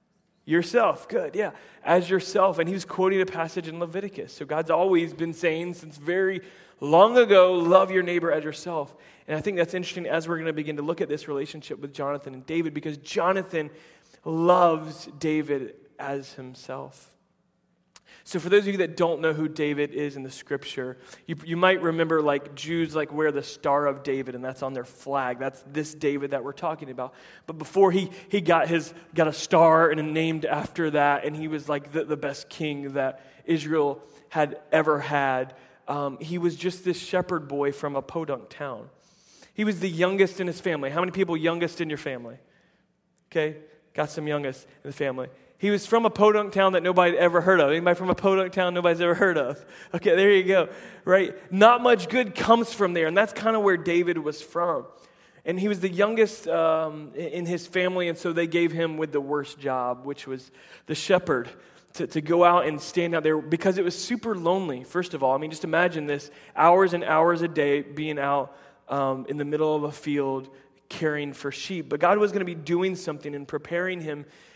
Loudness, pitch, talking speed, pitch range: -25 LUFS, 165 Hz, 210 wpm, 145-180 Hz